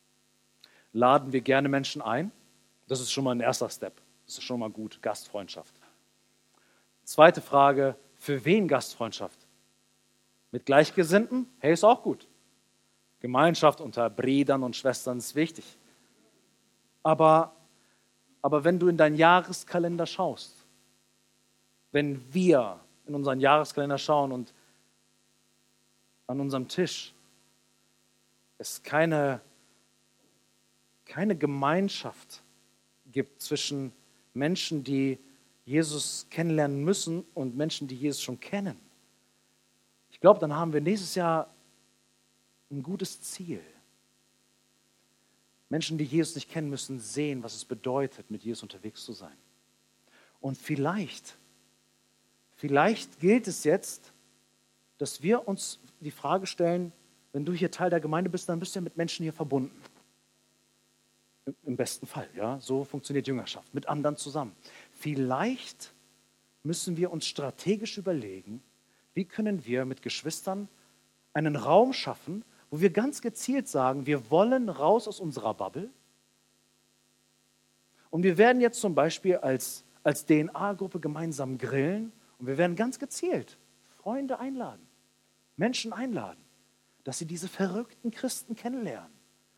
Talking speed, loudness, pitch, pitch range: 125 wpm, -28 LUFS, 145 Hz, 125-175 Hz